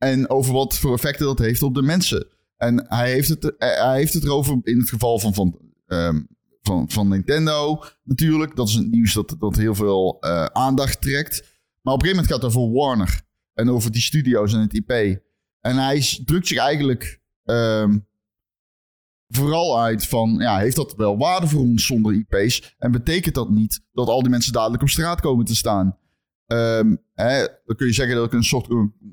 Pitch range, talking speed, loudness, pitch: 105-135 Hz, 200 wpm, -20 LUFS, 120 Hz